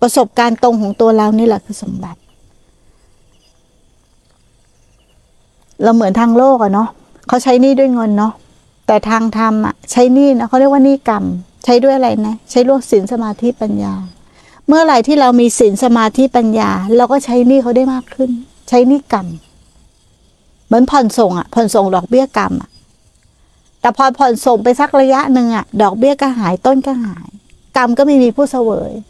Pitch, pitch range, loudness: 240 Hz, 215-260 Hz, -12 LUFS